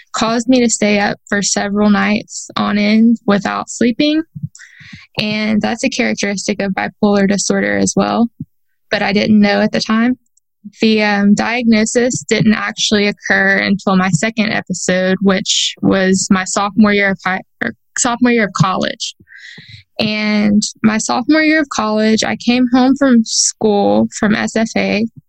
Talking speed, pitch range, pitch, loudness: 150 wpm, 200-230 Hz, 210 Hz, -14 LUFS